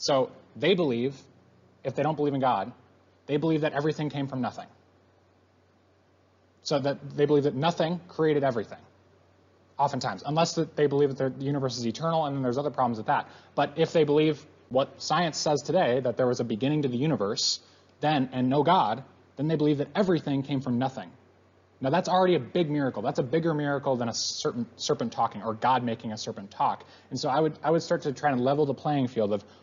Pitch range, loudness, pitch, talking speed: 115-150 Hz, -27 LUFS, 140 Hz, 215 wpm